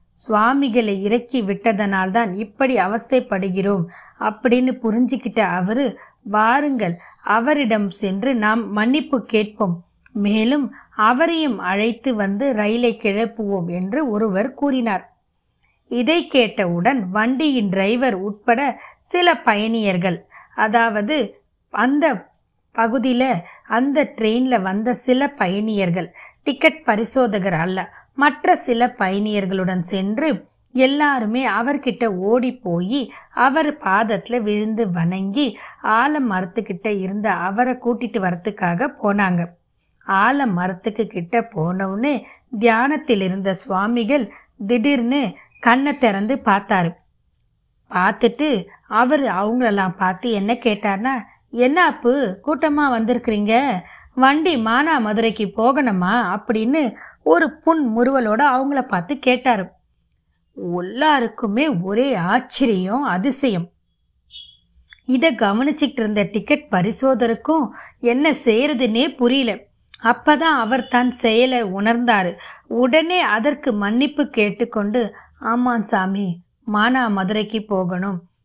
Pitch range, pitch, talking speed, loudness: 200-260 Hz, 230 Hz, 90 wpm, -19 LUFS